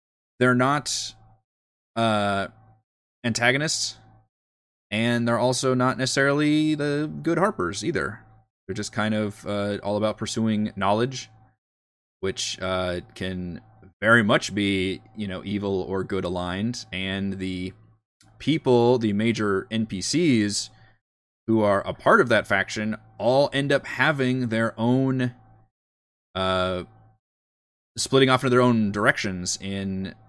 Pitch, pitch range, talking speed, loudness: 110 Hz, 95-120 Hz, 120 wpm, -24 LUFS